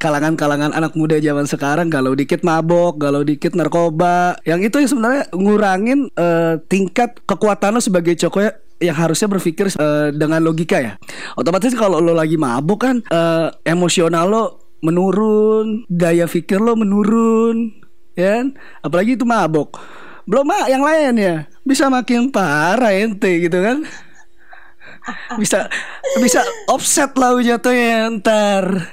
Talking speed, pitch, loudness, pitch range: 135 wpm, 190 Hz, -15 LUFS, 165-230 Hz